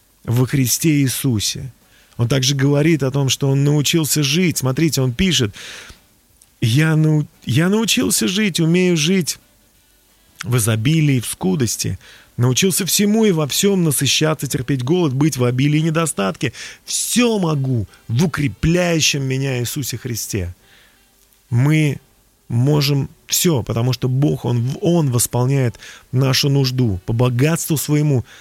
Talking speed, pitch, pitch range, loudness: 130 wpm, 140 Hz, 120-160 Hz, -17 LUFS